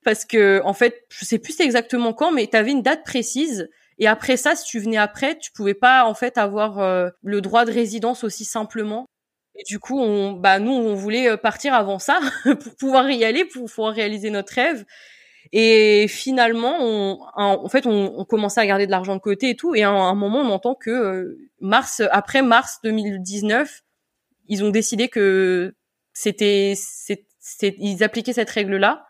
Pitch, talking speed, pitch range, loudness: 220 Hz, 195 wpm, 205-245 Hz, -19 LUFS